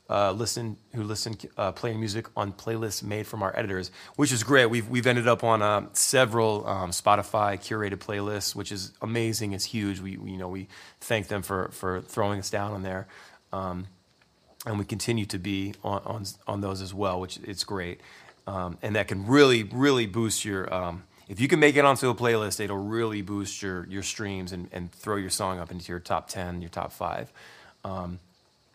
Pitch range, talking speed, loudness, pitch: 95-115 Hz, 215 wpm, -27 LUFS, 100 Hz